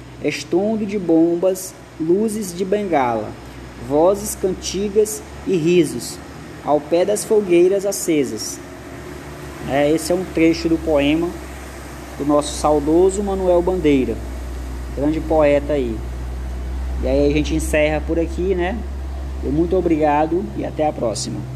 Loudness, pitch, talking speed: -19 LUFS, 150 Hz, 125 wpm